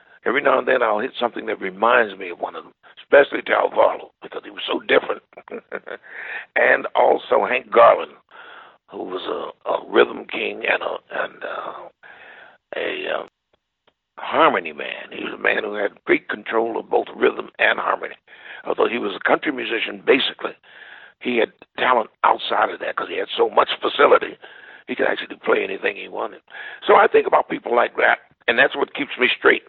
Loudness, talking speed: -20 LUFS, 185 wpm